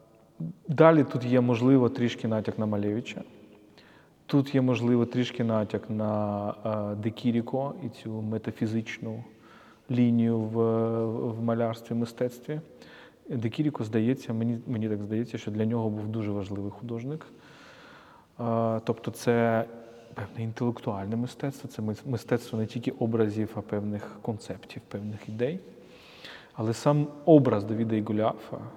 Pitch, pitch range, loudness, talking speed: 115 Hz, 110-120 Hz, -28 LUFS, 120 wpm